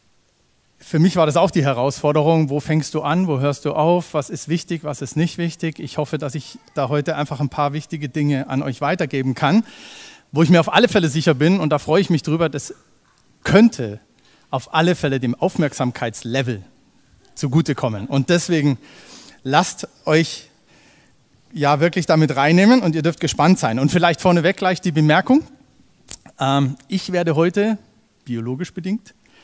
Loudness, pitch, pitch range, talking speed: -18 LUFS, 155 Hz, 145-175 Hz, 170 wpm